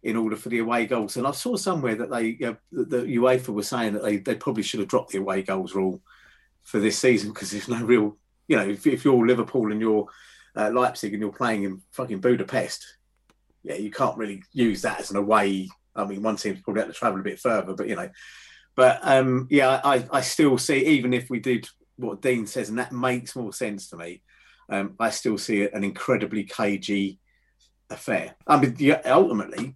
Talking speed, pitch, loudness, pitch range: 220 wpm, 110 Hz, -24 LUFS, 100-125 Hz